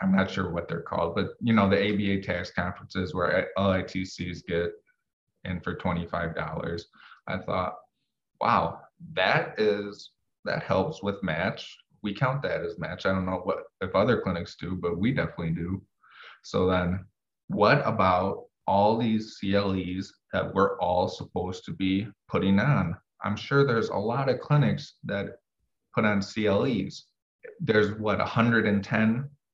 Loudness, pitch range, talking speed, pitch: -27 LUFS, 90-105 Hz, 150 wpm, 95 Hz